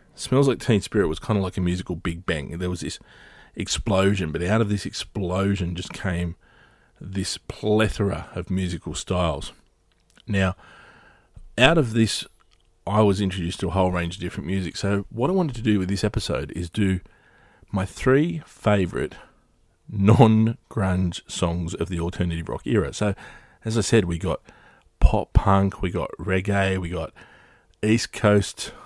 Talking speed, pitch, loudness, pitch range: 165 wpm, 95 Hz, -24 LUFS, 90-105 Hz